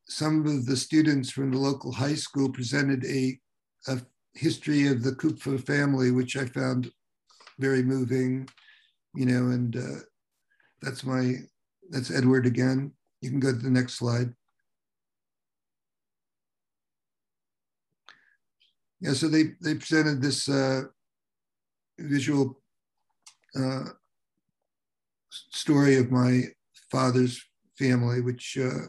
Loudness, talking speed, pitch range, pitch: -27 LUFS, 110 wpm, 125-140 Hz, 130 Hz